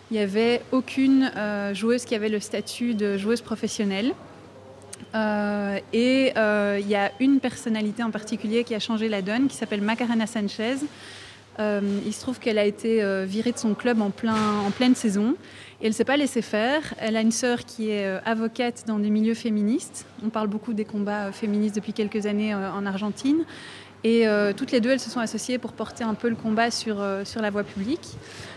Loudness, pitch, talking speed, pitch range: -25 LUFS, 220 Hz, 215 wpm, 210-235 Hz